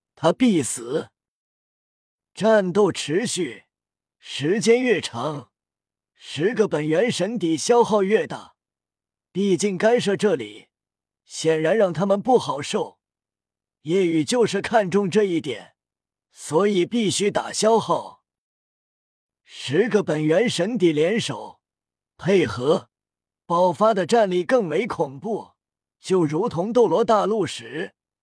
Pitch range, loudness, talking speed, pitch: 175-225 Hz, -21 LUFS, 165 characters per minute, 200 Hz